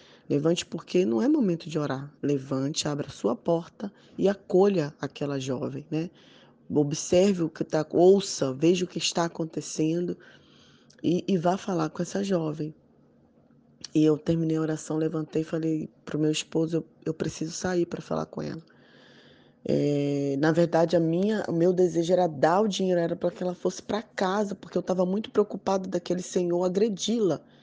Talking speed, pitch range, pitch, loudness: 175 wpm, 155-185 Hz, 170 Hz, -27 LUFS